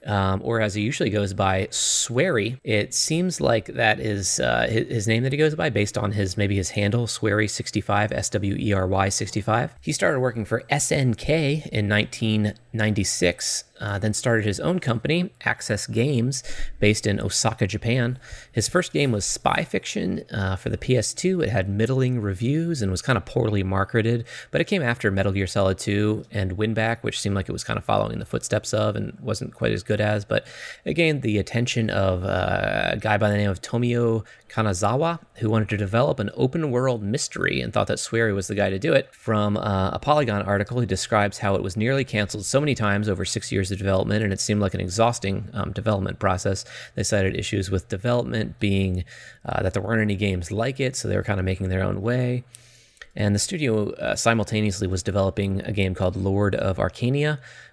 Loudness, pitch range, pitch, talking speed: -23 LUFS, 100-120 Hz, 105 Hz, 200 wpm